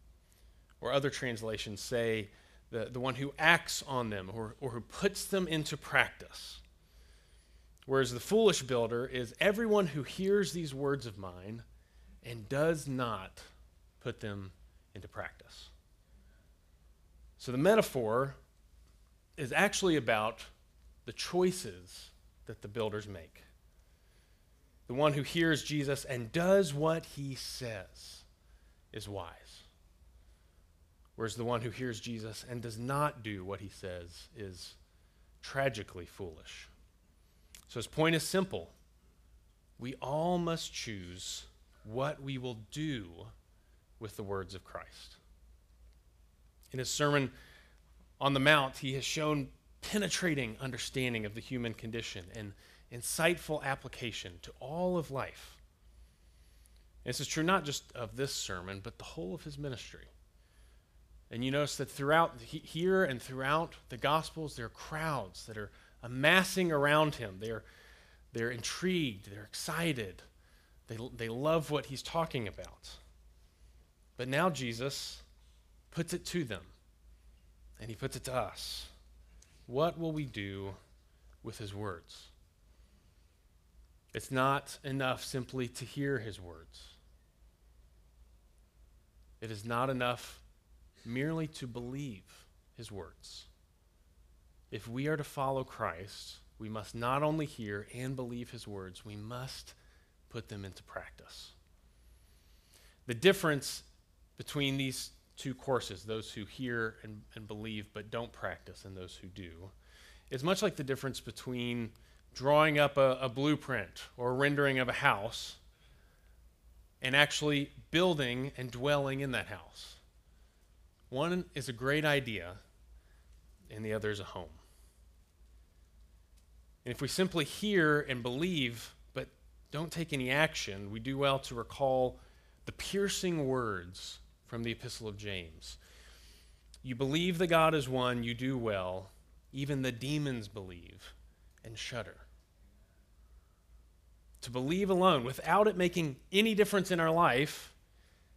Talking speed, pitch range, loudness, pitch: 130 wpm, 80-135 Hz, -34 LUFS, 110 Hz